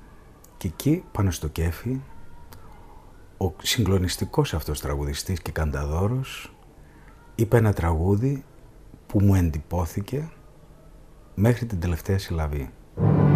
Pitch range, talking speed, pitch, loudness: 85-120 Hz, 95 wpm, 95 Hz, -25 LUFS